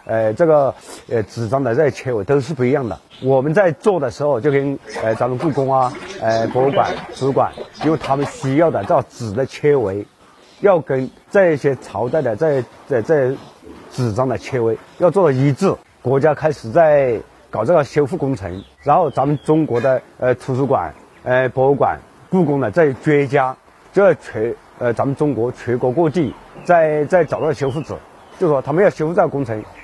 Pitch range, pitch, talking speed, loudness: 125-150 Hz, 135 Hz, 265 characters per minute, -17 LUFS